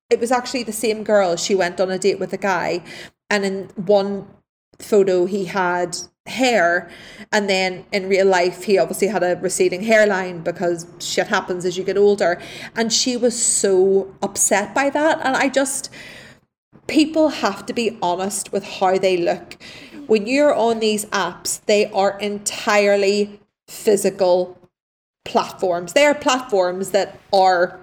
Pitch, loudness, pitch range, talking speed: 195 Hz, -19 LUFS, 185-220 Hz, 155 wpm